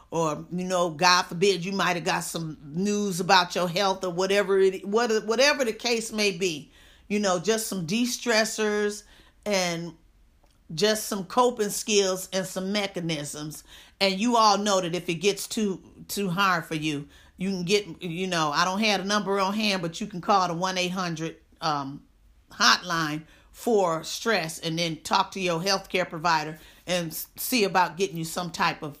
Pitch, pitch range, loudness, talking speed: 190 Hz, 170-205 Hz, -25 LUFS, 175 wpm